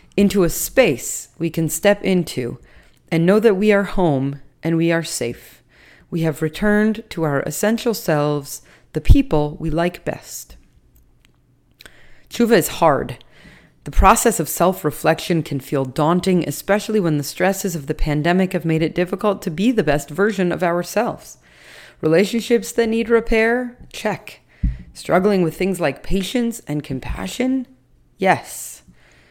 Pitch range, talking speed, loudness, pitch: 155-210 Hz, 145 wpm, -19 LUFS, 175 Hz